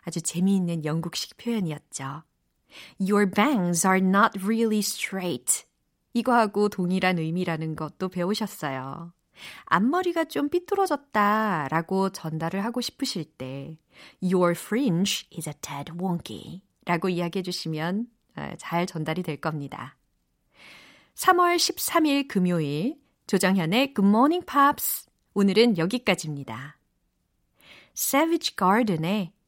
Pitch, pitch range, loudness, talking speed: 190 Hz, 165-230 Hz, -25 LUFS, 340 characters per minute